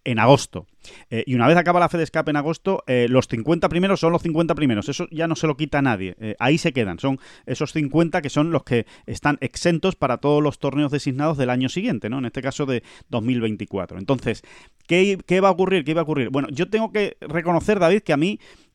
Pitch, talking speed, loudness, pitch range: 150 Hz, 240 wpm, -21 LUFS, 125-170 Hz